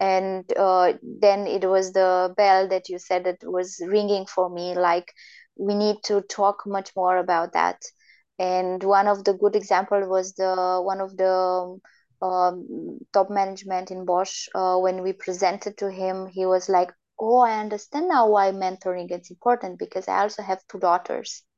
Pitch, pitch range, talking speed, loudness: 190 Hz, 185-200 Hz, 175 wpm, -23 LUFS